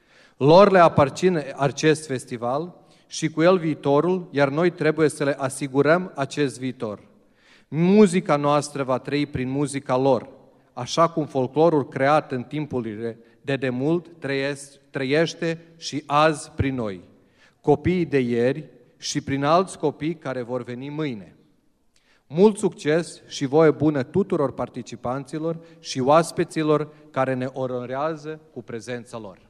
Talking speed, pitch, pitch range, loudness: 130 wpm, 145 Hz, 130-160 Hz, -22 LUFS